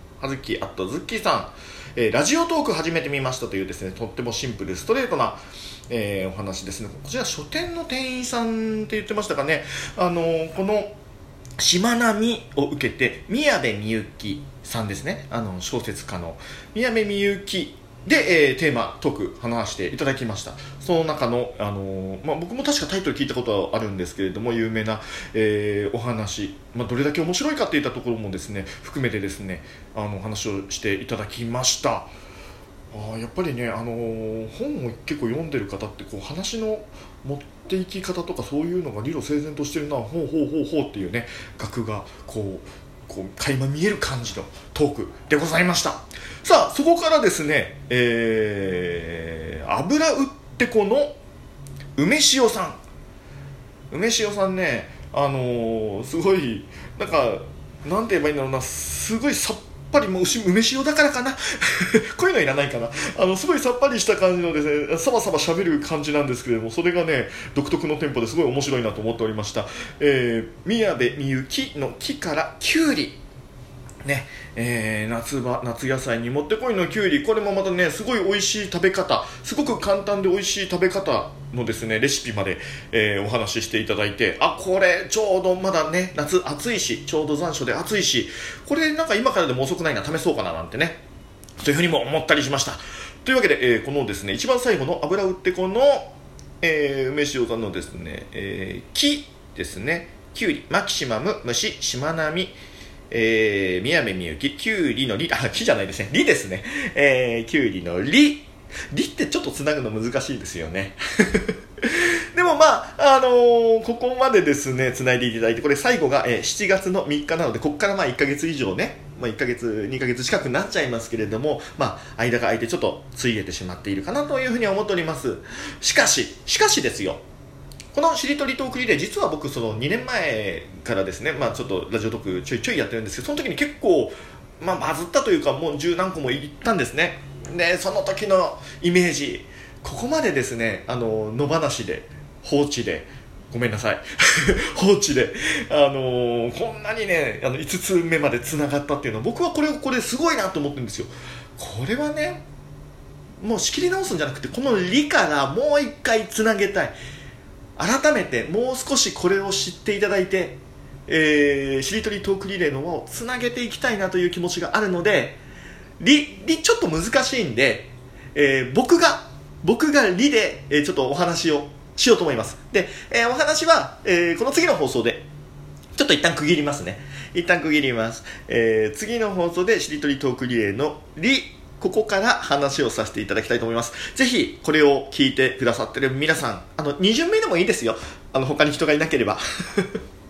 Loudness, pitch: -22 LUFS, 145 Hz